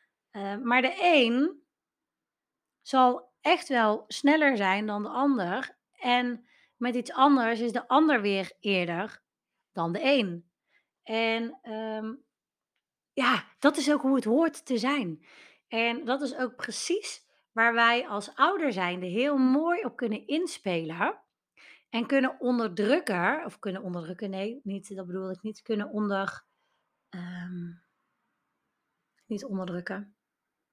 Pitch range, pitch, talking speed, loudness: 200-275 Hz, 235 Hz, 130 wpm, -28 LUFS